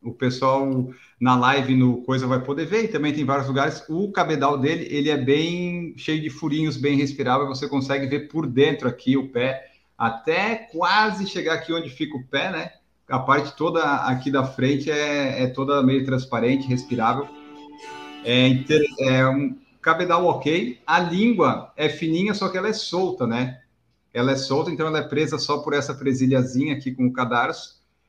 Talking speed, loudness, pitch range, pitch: 180 wpm, -22 LUFS, 130-155 Hz, 140 Hz